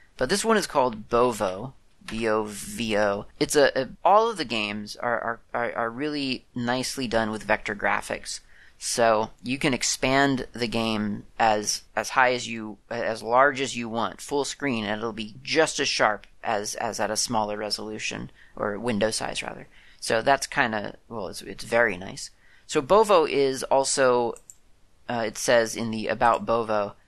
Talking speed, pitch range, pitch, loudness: 170 wpm, 110-130 Hz, 115 Hz, -25 LUFS